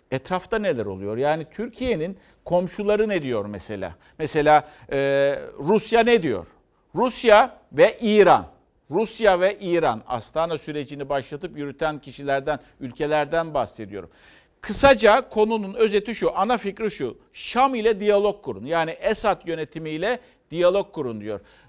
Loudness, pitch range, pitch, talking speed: -22 LUFS, 150-215 Hz, 175 Hz, 120 wpm